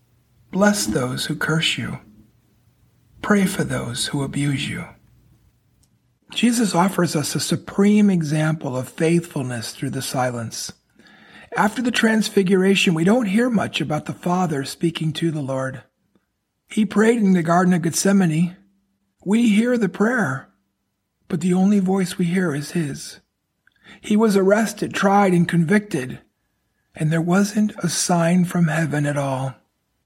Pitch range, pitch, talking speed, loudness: 145-200 Hz, 175 Hz, 140 wpm, -20 LUFS